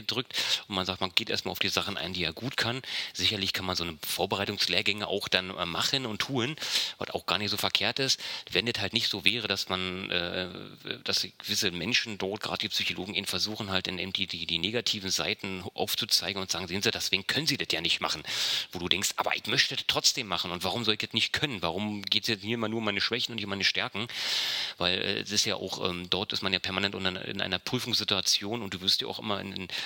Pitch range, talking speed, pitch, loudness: 95-110 Hz, 245 wpm, 100 Hz, -28 LUFS